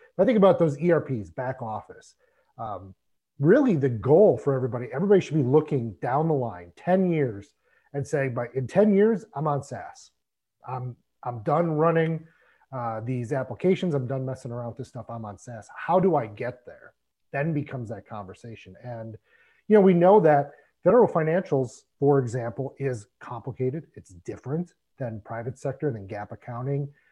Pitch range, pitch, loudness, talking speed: 120-160 Hz, 135 Hz, -24 LUFS, 170 wpm